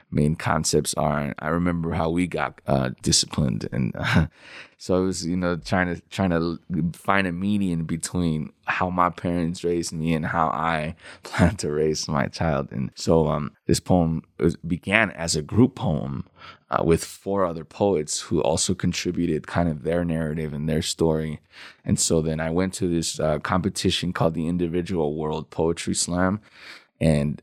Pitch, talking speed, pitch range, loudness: 85 Hz, 175 wpm, 80-90 Hz, -24 LUFS